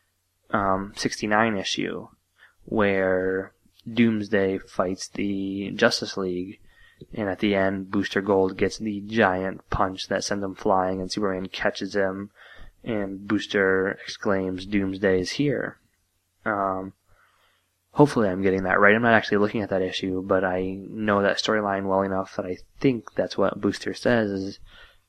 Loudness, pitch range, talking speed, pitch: -24 LUFS, 95-105 Hz, 145 wpm, 95 Hz